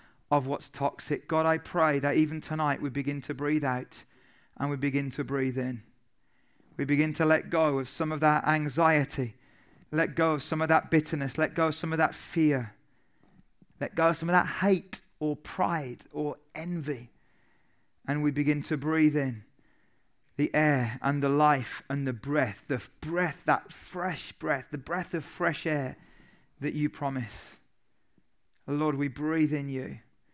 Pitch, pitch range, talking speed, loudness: 150 Hz, 140-160 Hz, 170 wpm, -29 LUFS